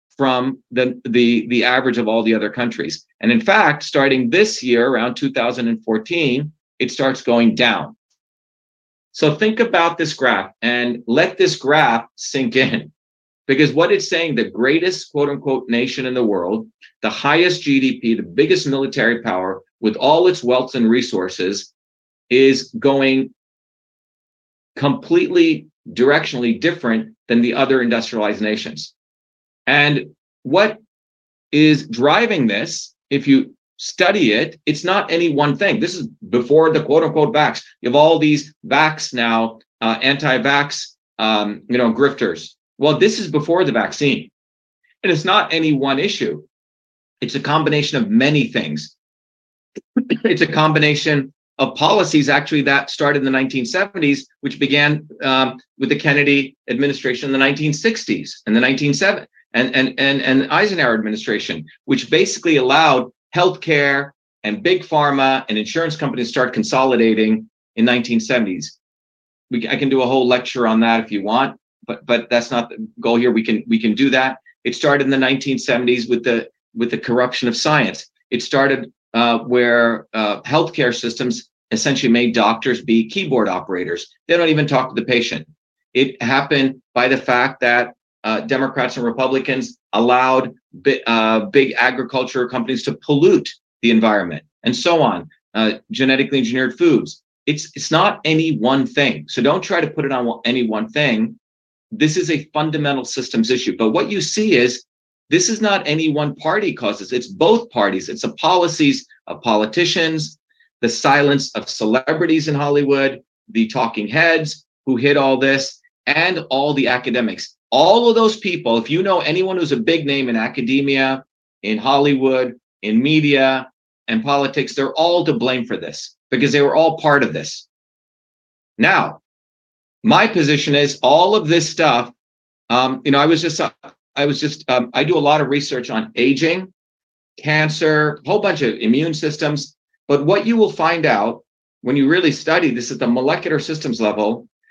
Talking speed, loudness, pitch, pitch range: 160 wpm, -17 LUFS, 135 Hz, 120-155 Hz